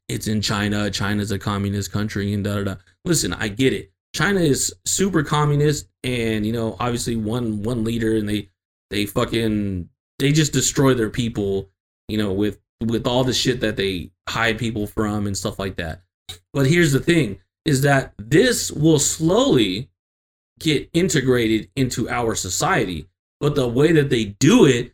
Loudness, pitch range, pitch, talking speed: -20 LUFS, 100-130 Hz, 110 Hz, 175 wpm